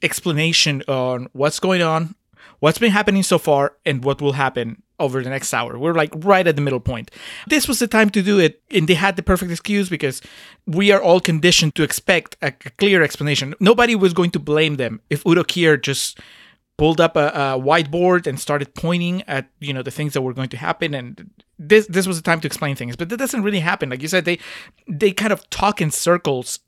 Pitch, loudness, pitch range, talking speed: 165 Hz, -18 LUFS, 140-185 Hz, 225 wpm